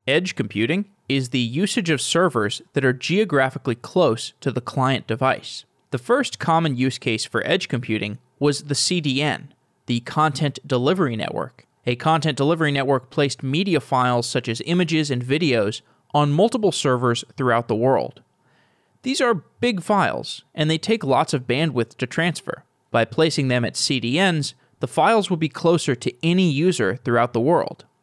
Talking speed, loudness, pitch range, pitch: 165 wpm, -21 LUFS, 125-165 Hz, 145 Hz